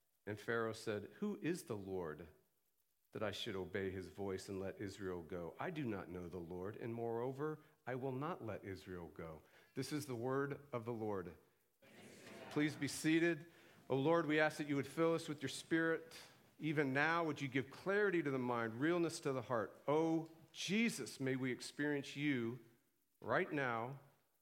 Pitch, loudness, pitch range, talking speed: 135 Hz, -41 LUFS, 115-155 Hz, 180 wpm